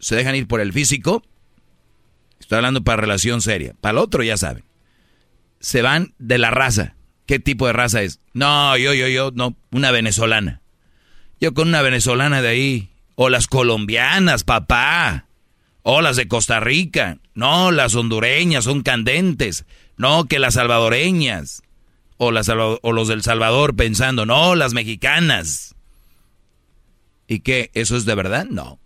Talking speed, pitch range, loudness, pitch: 155 wpm, 110-140 Hz, -17 LUFS, 125 Hz